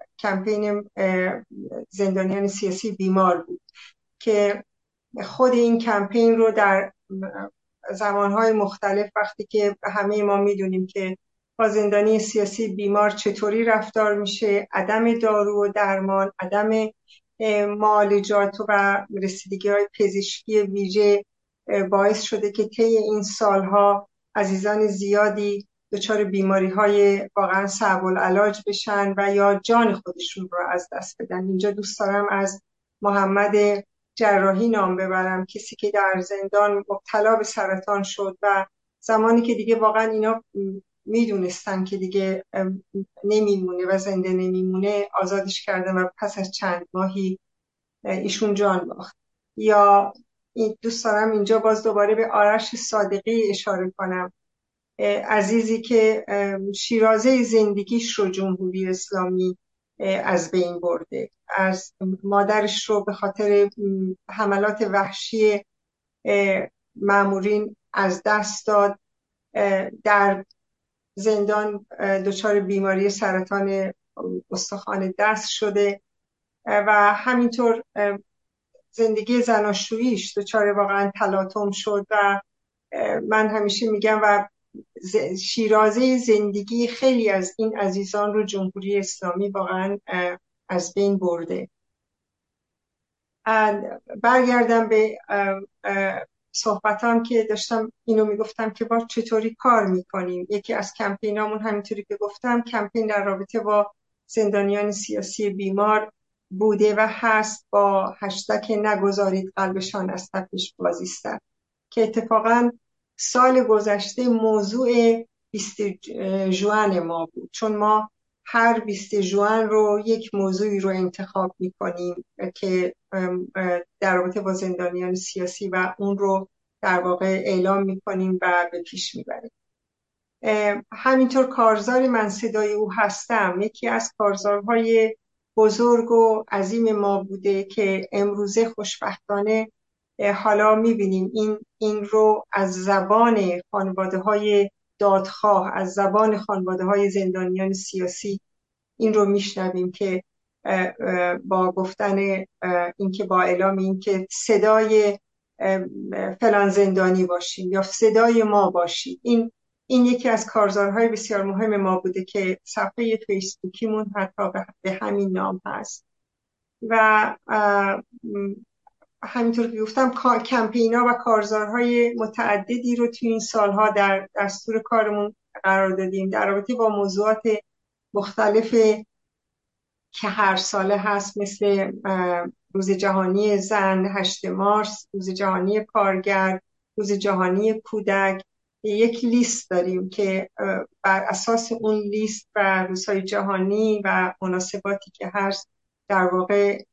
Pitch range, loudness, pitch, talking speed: 195-215 Hz, -22 LUFS, 205 Hz, 110 wpm